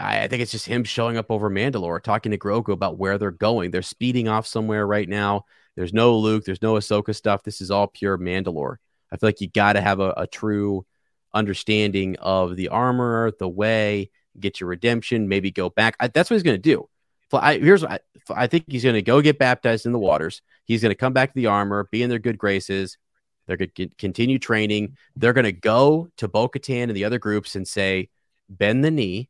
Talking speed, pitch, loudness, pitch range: 225 wpm, 105 Hz, -21 LUFS, 100-120 Hz